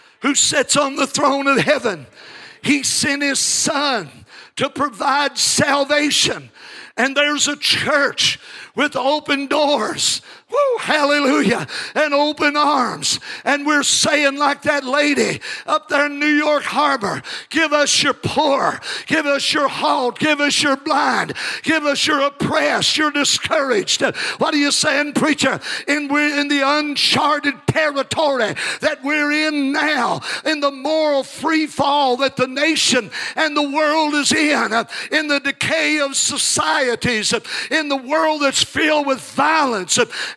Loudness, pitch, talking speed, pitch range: -17 LUFS, 290 Hz, 145 wpm, 275-300 Hz